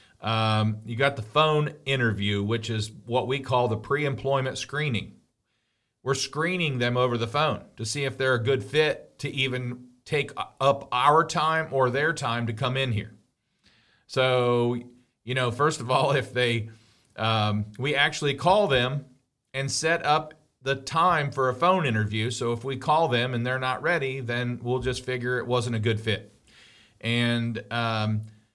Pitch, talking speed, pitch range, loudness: 125 Hz, 175 wpm, 115-140 Hz, -26 LUFS